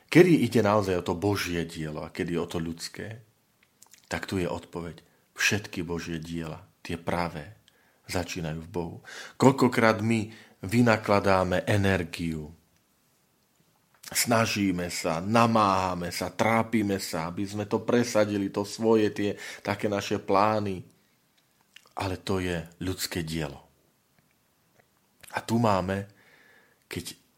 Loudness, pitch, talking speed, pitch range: -27 LUFS, 95 Hz, 115 wpm, 85-110 Hz